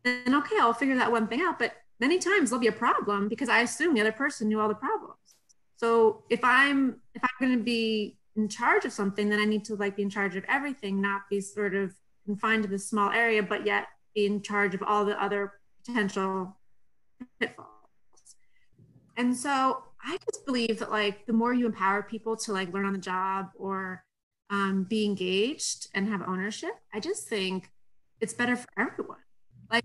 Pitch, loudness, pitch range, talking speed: 215 Hz, -28 LUFS, 200-245 Hz, 200 wpm